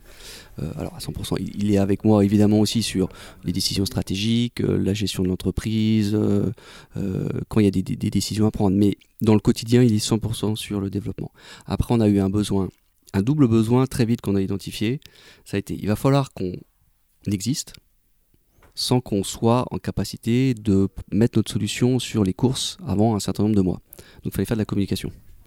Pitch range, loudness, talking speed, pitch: 95-115 Hz, -22 LUFS, 200 wpm, 105 Hz